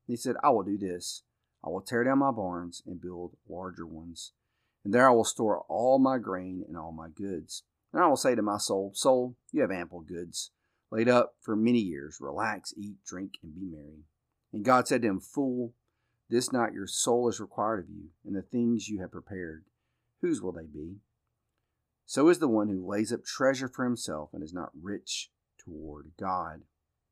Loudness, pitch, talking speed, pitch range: -29 LUFS, 100 Hz, 200 wpm, 90-120 Hz